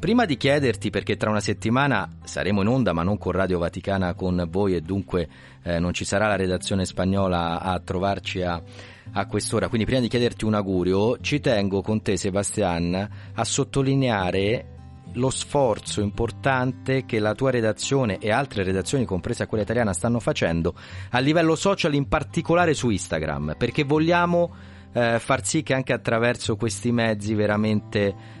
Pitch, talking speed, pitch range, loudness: 105 Hz, 155 wpm, 95-125 Hz, -23 LUFS